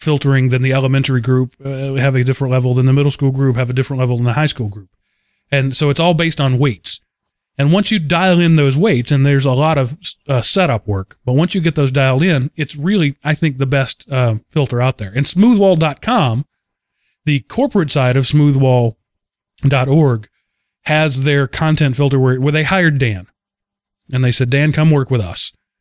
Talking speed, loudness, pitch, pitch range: 200 wpm, -14 LUFS, 140 Hz, 130-155 Hz